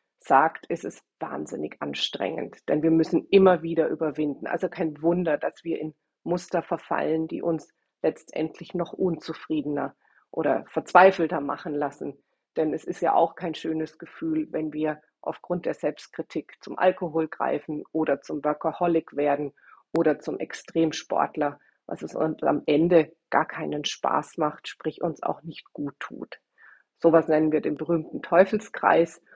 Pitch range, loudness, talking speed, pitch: 155-170 Hz, -26 LUFS, 150 wpm, 160 Hz